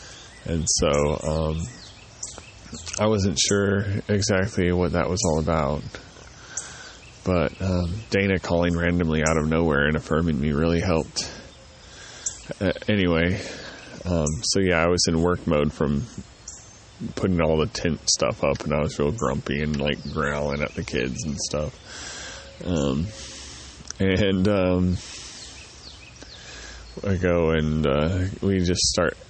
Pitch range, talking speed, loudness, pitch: 75-95 Hz, 135 wpm, -23 LUFS, 85 Hz